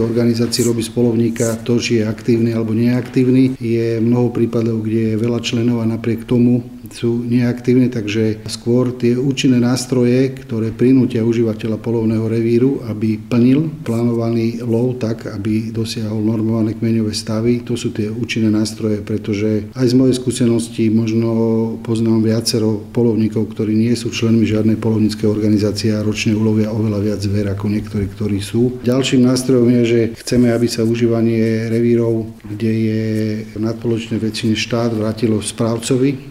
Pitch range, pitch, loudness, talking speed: 110-120 Hz, 115 Hz, -16 LUFS, 145 wpm